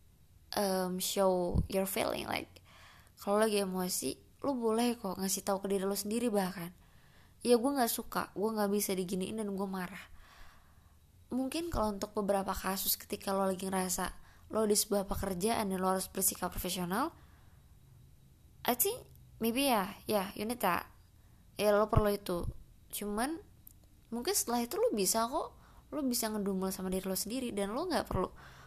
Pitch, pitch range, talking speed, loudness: 200 Hz, 185-225 Hz, 165 wpm, -34 LUFS